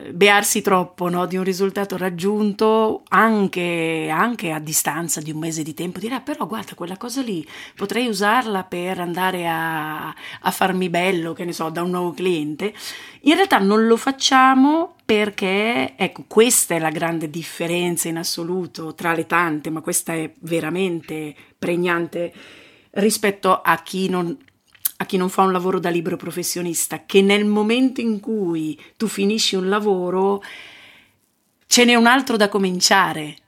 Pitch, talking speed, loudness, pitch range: 185 Hz, 160 wpm, -19 LUFS, 170-210 Hz